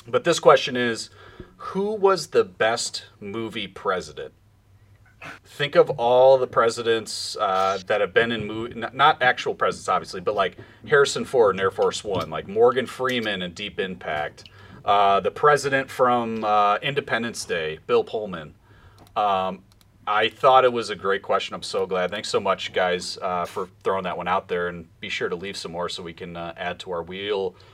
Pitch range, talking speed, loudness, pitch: 100-135 Hz, 180 wpm, -23 LUFS, 115 Hz